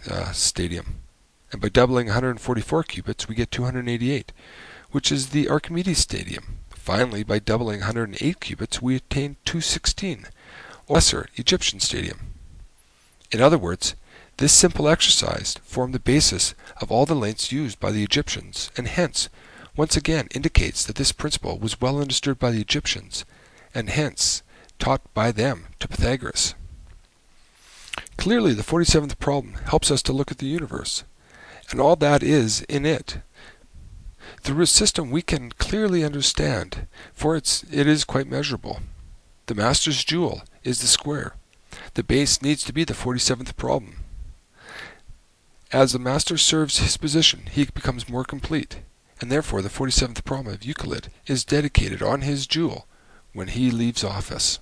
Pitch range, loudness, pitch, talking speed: 105-145 Hz, -22 LUFS, 130 Hz, 150 wpm